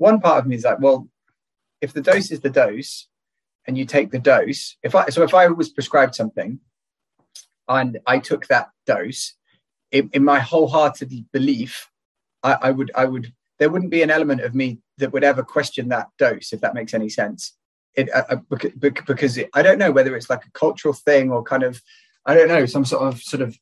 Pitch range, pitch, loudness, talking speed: 130-150 Hz, 140 Hz, -19 LUFS, 210 wpm